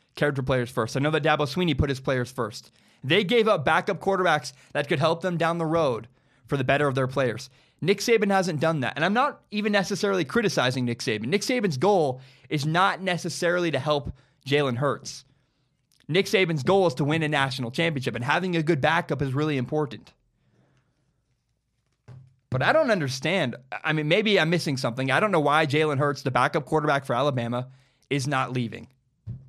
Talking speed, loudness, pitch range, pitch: 190 wpm, -24 LUFS, 130-170 Hz, 145 Hz